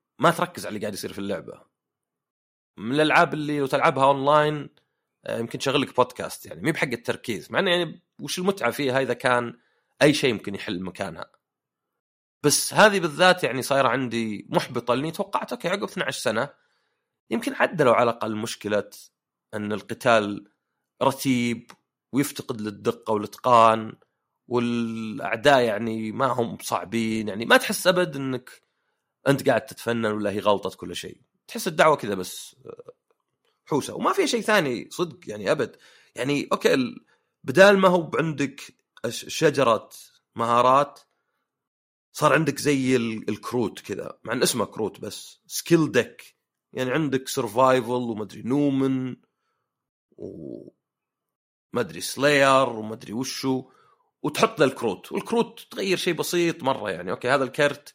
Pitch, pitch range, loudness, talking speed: 135 Hz, 115-160 Hz, -24 LUFS, 135 wpm